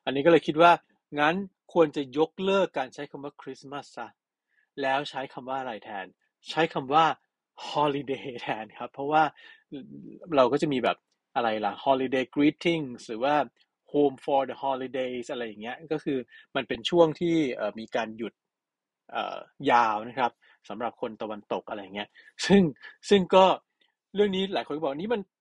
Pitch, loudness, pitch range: 145 Hz, -27 LUFS, 130-165 Hz